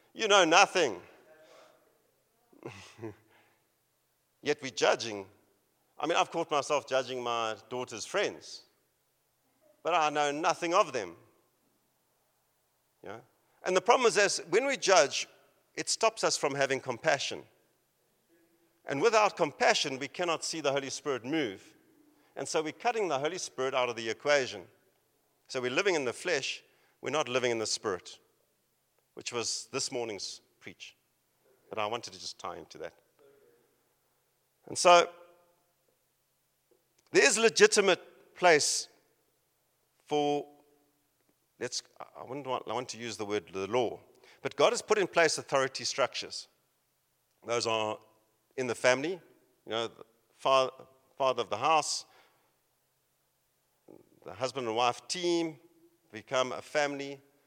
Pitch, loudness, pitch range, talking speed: 140 Hz, -30 LUFS, 120-170 Hz, 135 wpm